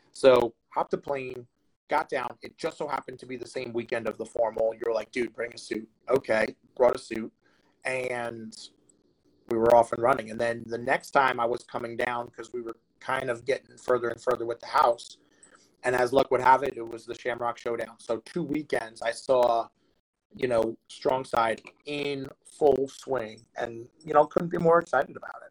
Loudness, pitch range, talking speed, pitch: -28 LUFS, 115-130 Hz, 205 wpm, 120 Hz